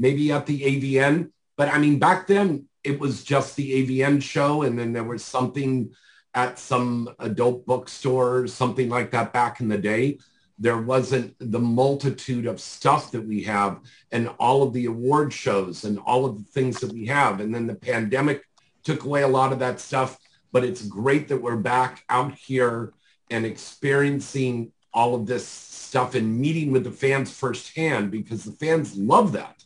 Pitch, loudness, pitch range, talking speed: 125 Hz, -23 LUFS, 120-140 Hz, 180 wpm